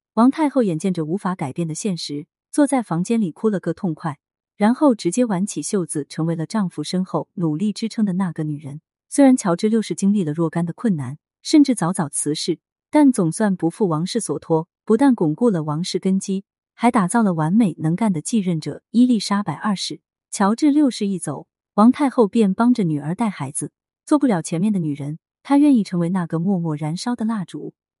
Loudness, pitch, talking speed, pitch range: -20 LUFS, 190 Hz, 305 characters per minute, 160-225 Hz